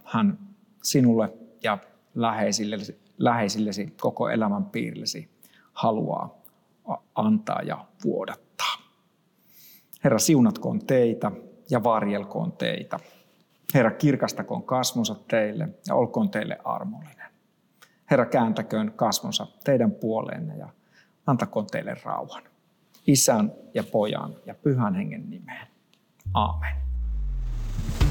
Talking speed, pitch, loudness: 90 wpm, 145 Hz, -26 LUFS